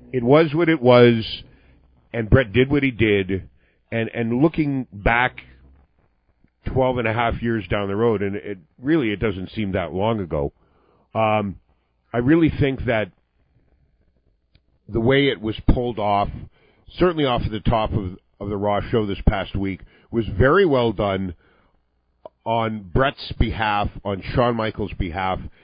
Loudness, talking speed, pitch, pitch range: -21 LUFS, 155 wpm, 105 Hz, 95-120 Hz